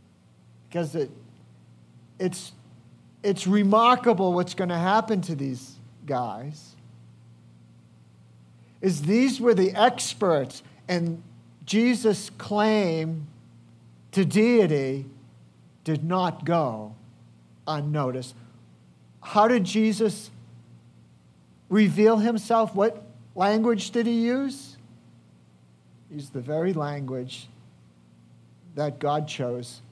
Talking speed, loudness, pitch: 85 wpm, -24 LUFS, 145 Hz